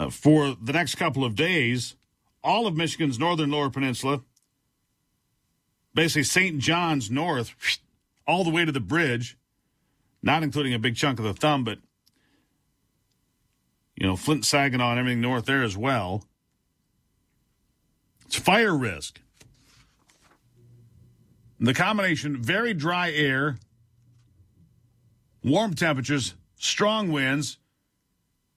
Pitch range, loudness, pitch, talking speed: 120-155 Hz, -24 LUFS, 135 Hz, 115 wpm